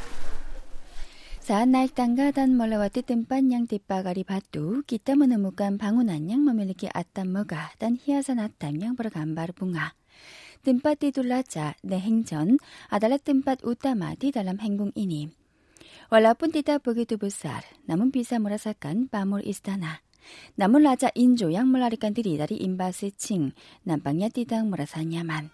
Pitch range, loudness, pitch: 190-250 Hz, -26 LUFS, 220 Hz